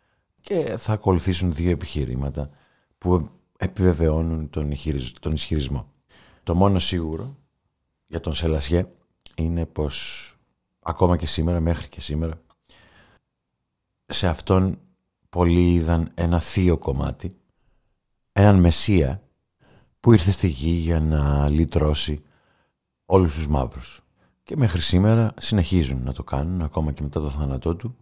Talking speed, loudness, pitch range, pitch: 120 wpm, -22 LUFS, 75-90 Hz, 85 Hz